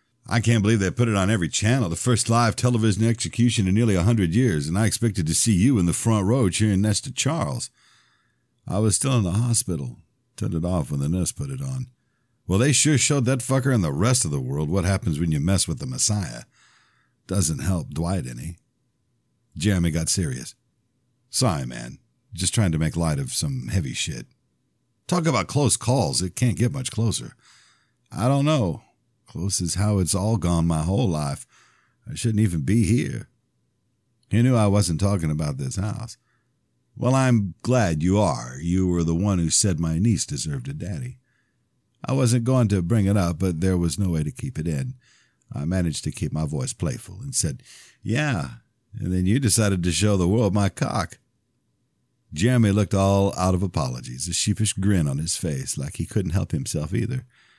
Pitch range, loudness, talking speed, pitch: 90-125 Hz, -23 LUFS, 195 wpm, 110 Hz